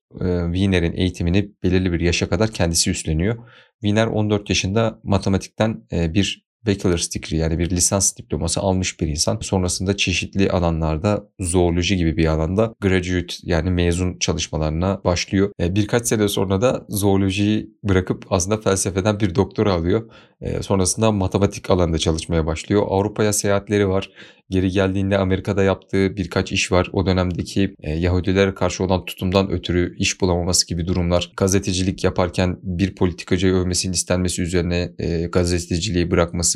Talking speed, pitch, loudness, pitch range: 130 wpm, 95 Hz, -20 LUFS, 90-100 Hz